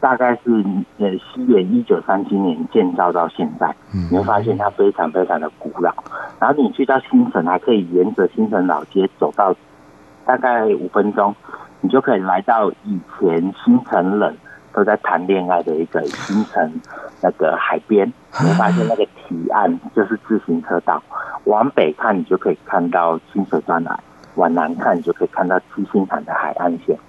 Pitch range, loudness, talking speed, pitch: 90-125 Hz, -18 LUFS, 265 characters per minute, 100 Hz